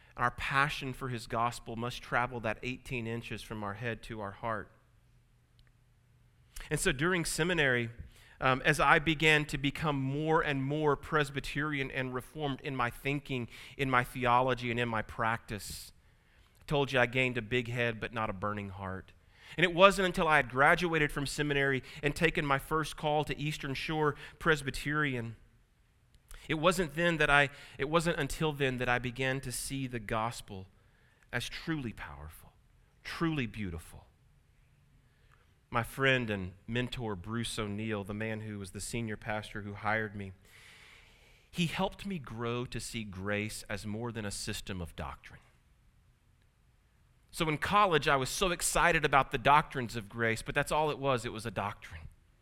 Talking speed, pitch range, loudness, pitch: 165 wpm, 110-145 Hz, -32 LUFS, 125 Hz